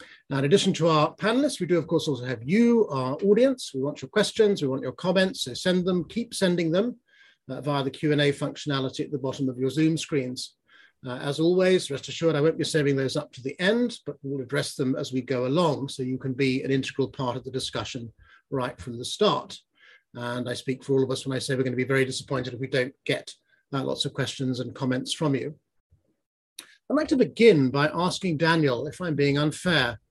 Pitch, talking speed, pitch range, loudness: 140 Hz, 230 wpm, 130-175 Hz, -25 LUFS